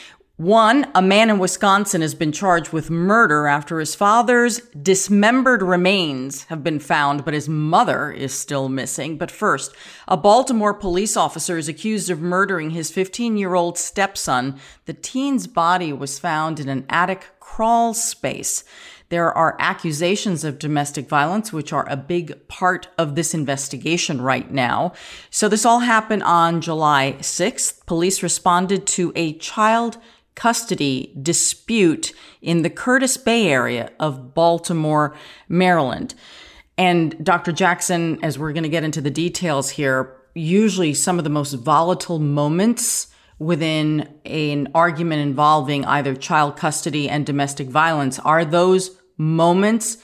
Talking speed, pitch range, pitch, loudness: 145 wpm, 150-190 Hz, 170 Hz, -19 LUFS